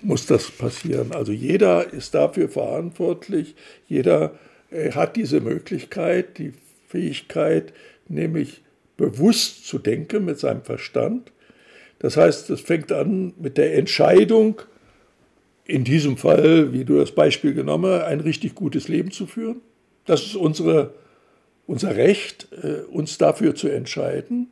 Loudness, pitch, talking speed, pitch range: -21 LUFS, 190 Hz, 130 wpm, 150-225 Hz